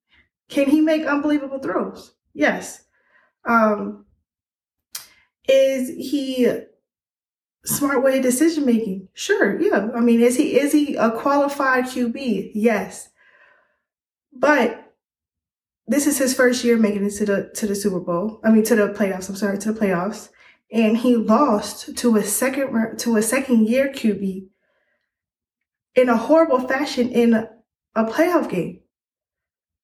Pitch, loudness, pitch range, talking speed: 235 Hz, -19 LUFS, 210-270 Hz, 135 wpm